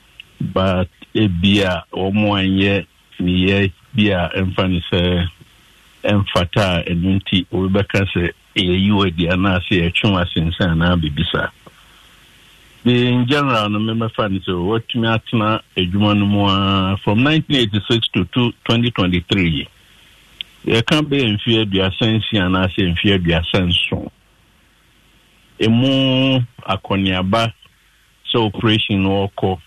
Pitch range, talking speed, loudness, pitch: 90-115 Hz, 130 wpm, -17 LUFS, 100 Hz